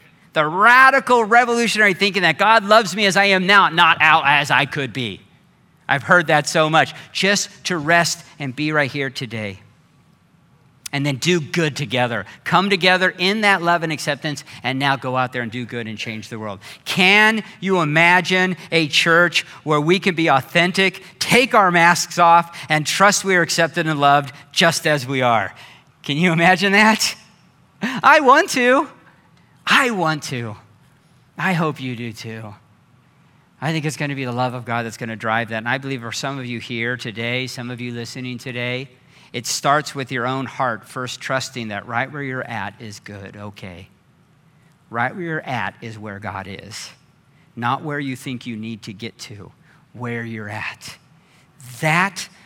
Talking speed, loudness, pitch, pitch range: 185 wpm, -17 LUFS, 145 Hz, 125-170 Hz